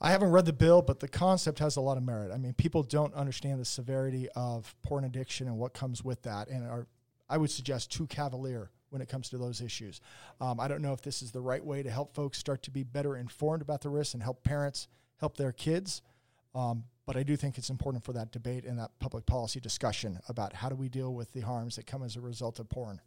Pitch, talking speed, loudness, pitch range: 130 Hz, 255 wpm, -34 LUFS, 120-140 Hz